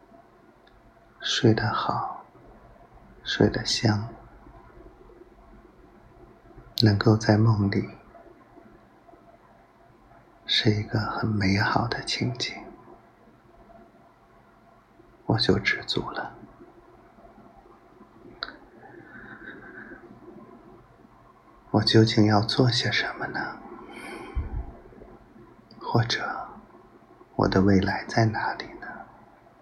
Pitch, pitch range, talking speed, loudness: 110 Hz, 105-115 Hz, 90 characters per minute, -25 LUFS